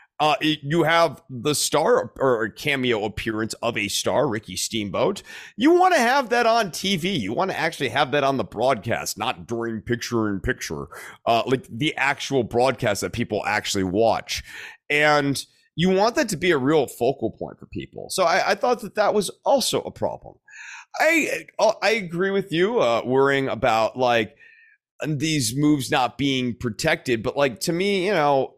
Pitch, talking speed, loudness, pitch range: 145 Hz, 175 wpm, -22 LUFS, 120-190 Hz